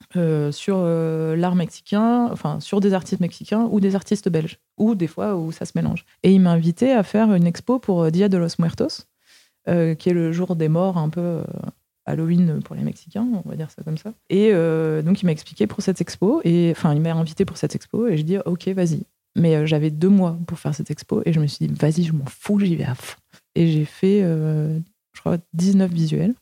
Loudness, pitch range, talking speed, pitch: -21 LUFS, 160-195 Hz, 240 wpm, 175 Hz